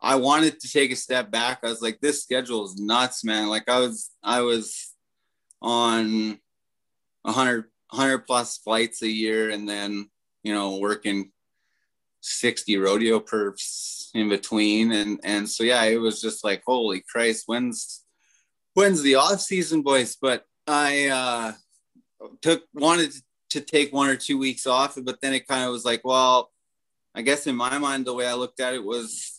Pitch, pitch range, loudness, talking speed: 120 Hz, 110-135 Hz, -23 LUFS, 175 wpm